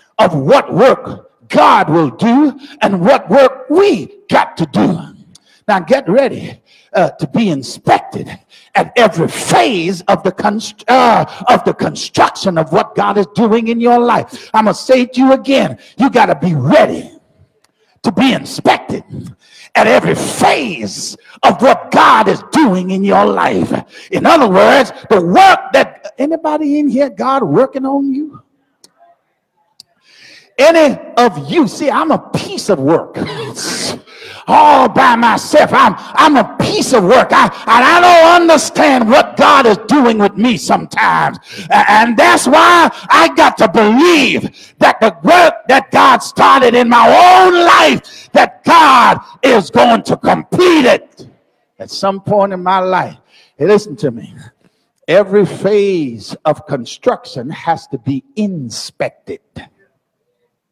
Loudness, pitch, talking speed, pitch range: -10 LUFS, 245 Hz, 150 wpm, 200-300 Hz